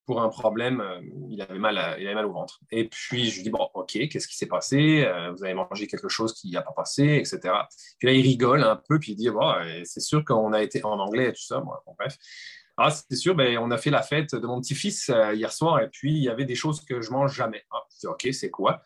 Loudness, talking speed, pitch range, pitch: -25 LUFS, 275 wpm, 110-145 Hz, 130 Hz